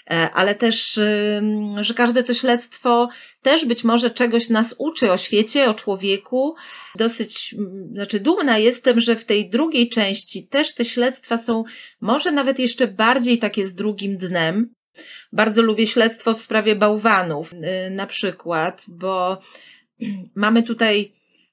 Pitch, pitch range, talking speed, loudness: 225 Hz, 200-240 Hz, 135 wpm, -19 LUFS